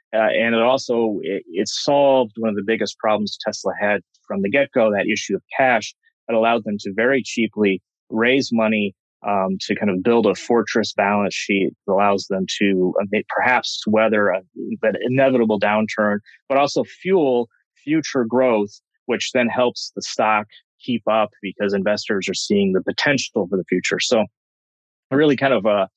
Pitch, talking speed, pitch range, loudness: 110 Hz, 170 wpm, 100-125 Hz, -20 LUFS